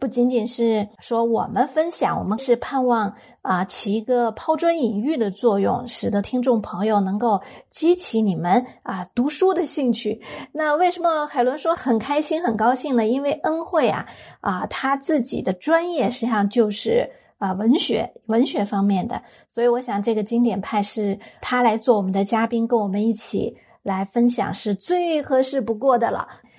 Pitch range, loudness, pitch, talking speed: 215-270 Hz, -21 LUFS, 235 Hz, 260 characters per minute